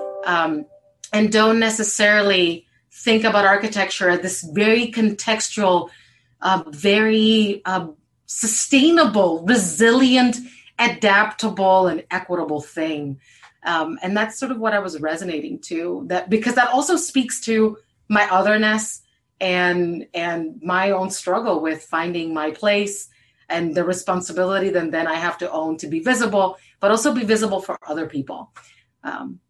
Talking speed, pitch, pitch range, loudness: 135 wpm, 190 Hz, 170-220 Hz, -19 LUFS